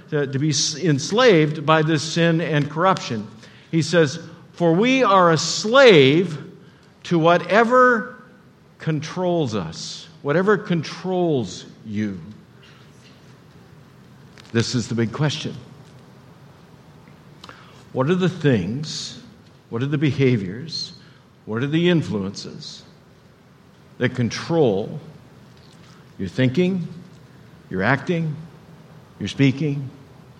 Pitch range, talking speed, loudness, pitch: 135-170 Hz, 95 wpm, -20 LUFS, 155 Hz